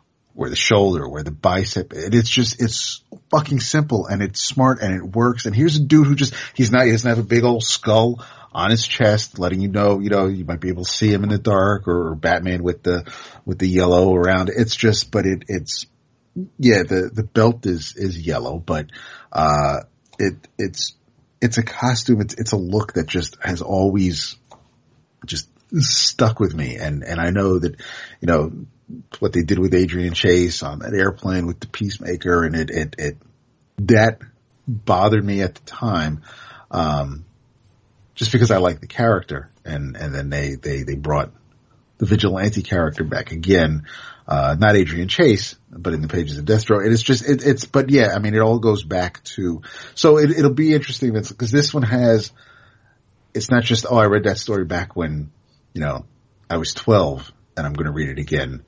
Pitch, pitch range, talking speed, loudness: 105 Hz, 90-120 Hz, 190 wpm, -19 LUFS